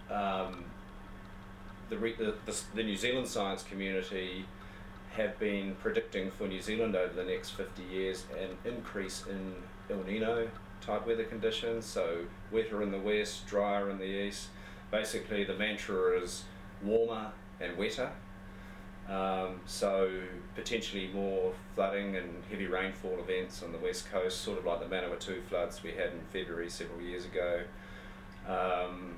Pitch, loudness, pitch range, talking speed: 100 Hz, -36 LUFS, 95-100 Hz, 150 wpm